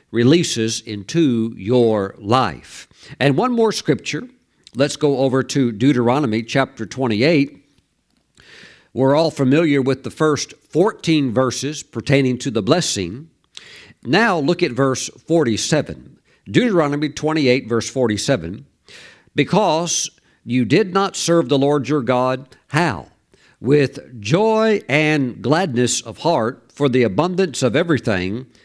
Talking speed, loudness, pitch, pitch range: 120 wpm, -18 LUFS, 135 Hz, 120-155 Hz